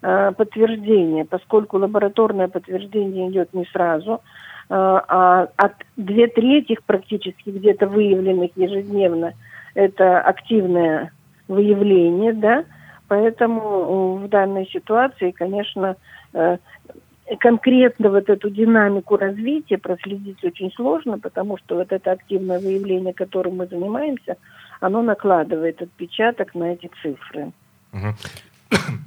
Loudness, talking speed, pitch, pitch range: -19 LUFS, 95 wpm, 195 Hz, 180-210 Hz